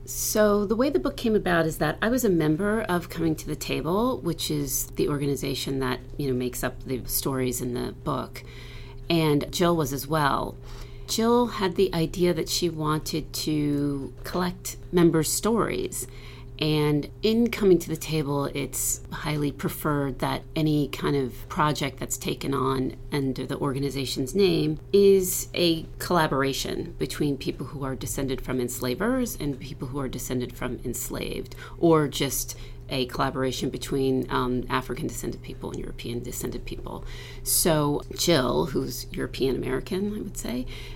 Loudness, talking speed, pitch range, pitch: -26 LUFS, 155 wpm, 130-165 Hz, 140 Hz